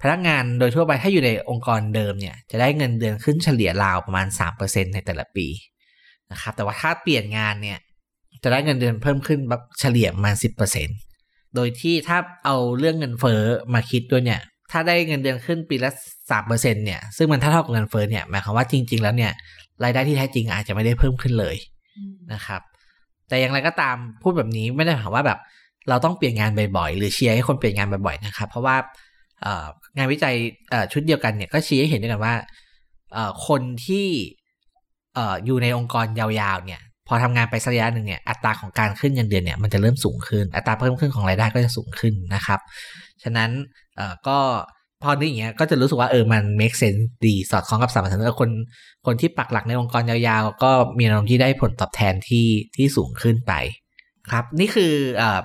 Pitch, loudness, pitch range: 120 Hz, -21 LUFS, 105-135 Hz